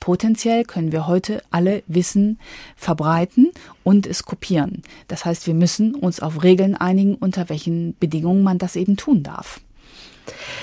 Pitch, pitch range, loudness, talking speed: 180 Hz, 170-200 Hz, -19 LUFS, 145 wpm